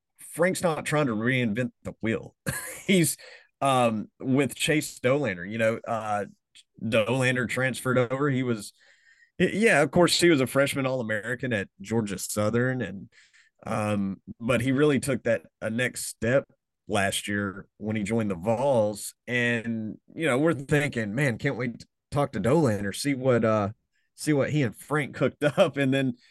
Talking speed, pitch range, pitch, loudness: 165 wpm, 110-145 Hz, 125 Hz, -26 LUFS